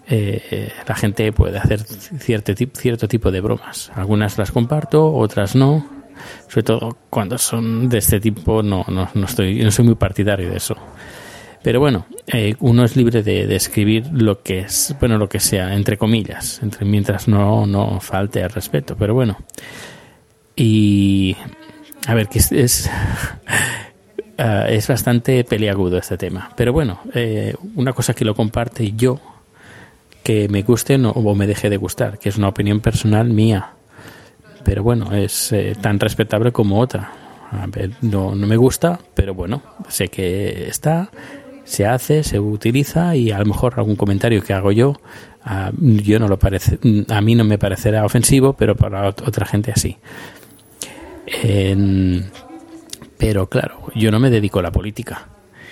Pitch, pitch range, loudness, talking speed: 110 Hz, 100-120 Hz, -17 LUFS, 165 wpm